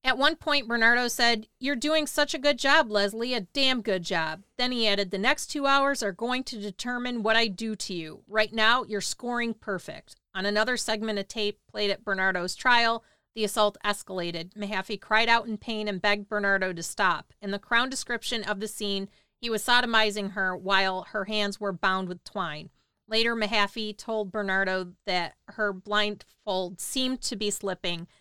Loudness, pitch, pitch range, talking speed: -27 LUFS, 210 Hz, 195-235 Hz, 185 wpm